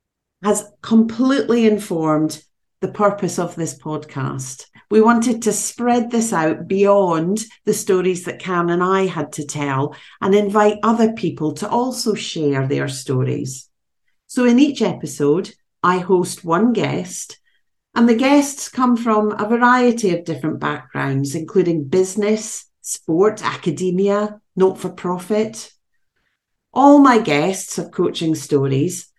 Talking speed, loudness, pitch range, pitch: 130 wpm, -18 LUFS, 160-220 Hz, 190 Hz